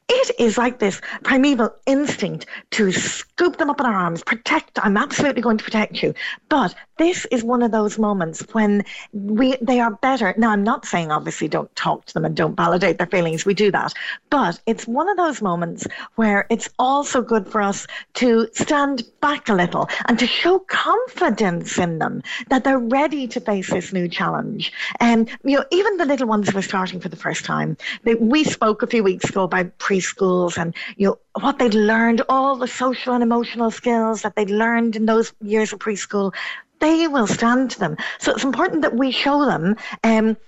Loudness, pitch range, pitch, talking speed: -19 LUFS, 205-265 Hz, 230 Hz, 200 wpm